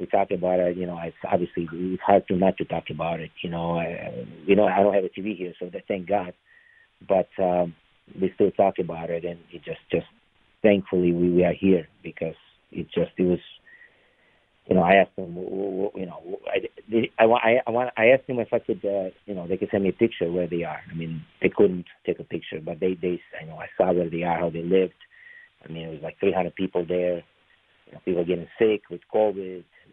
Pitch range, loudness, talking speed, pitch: 85-100 Hz, -25 LUFS, 235 wpm, 90 Hz